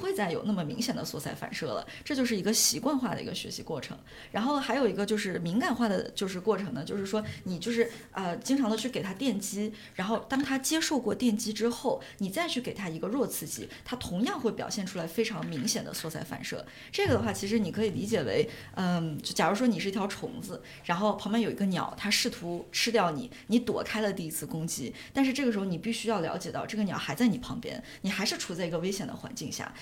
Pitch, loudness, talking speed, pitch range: 215 Hz, -31 LUFS, 360 characters per minute, 195-235 Hz